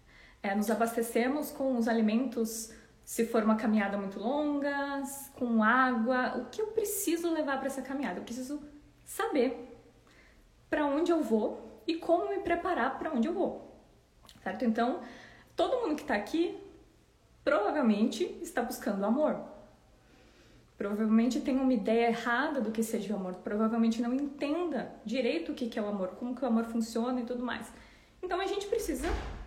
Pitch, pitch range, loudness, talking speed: 250 Hz, 230-295 Hz, -31 LUFS, 160 wpm